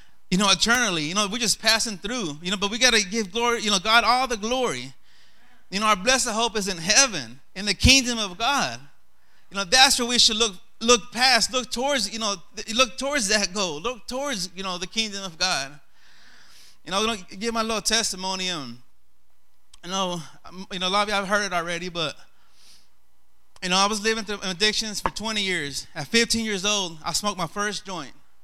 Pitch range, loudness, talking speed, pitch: 185-230 Hz, -22 LUFS, 225 wpm, 205 Hz